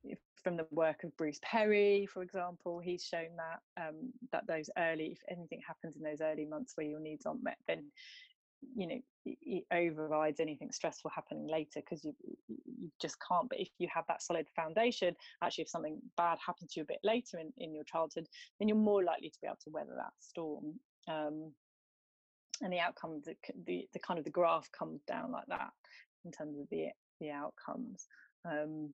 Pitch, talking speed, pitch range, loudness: 170 Hz, 195 wpm, 155-200 Hz, -39 LUFS